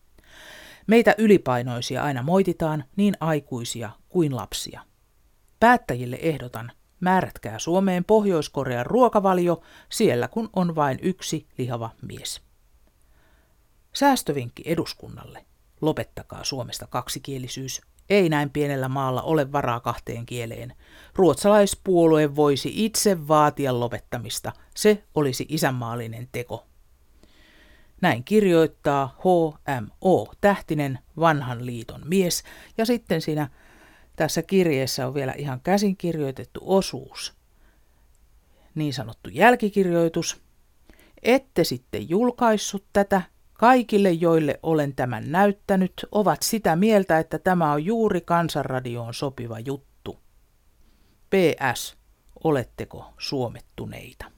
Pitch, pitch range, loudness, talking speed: 155 Hz, 125-190 Hz, -23 LUFS, 95 wpm